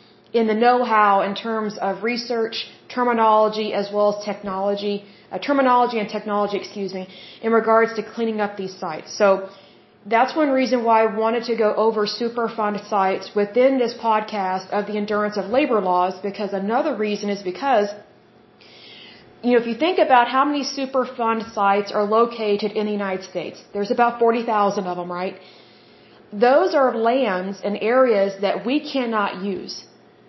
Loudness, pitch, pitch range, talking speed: -21 LUFS, 215 Hz, 200-235 Hz, 160 wpm